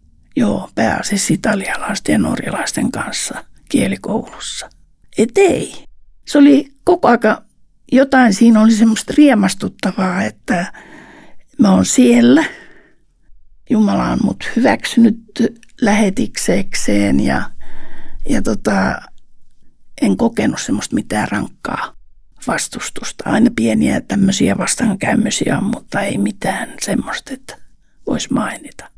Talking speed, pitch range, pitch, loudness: 95 wpm, 190-255 Hz, 225 Hz, -15 LUFS